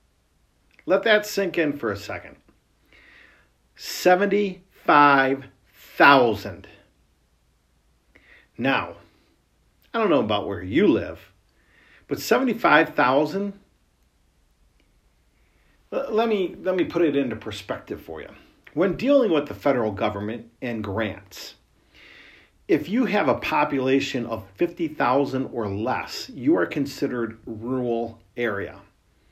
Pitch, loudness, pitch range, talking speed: 120 Hz, -23 LUFS, 100-160 Hz, 100 wpm